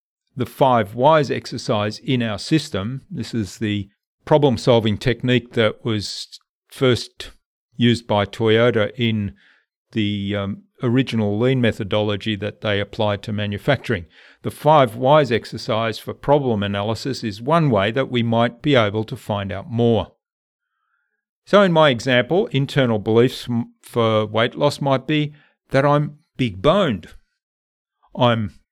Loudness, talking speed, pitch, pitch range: -20 LUFS, 135 wpm, 115 Hz, 105-135 Hz